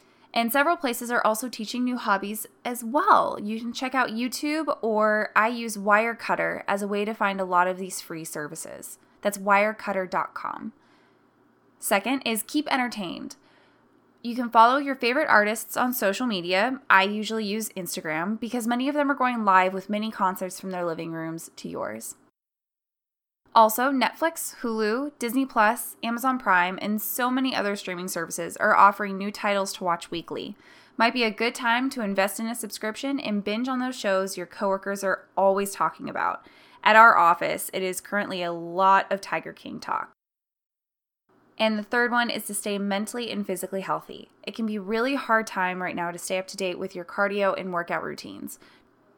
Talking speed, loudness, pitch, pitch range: 180 wpm, -25 LUFS, 215 Hz, 190-240 Hz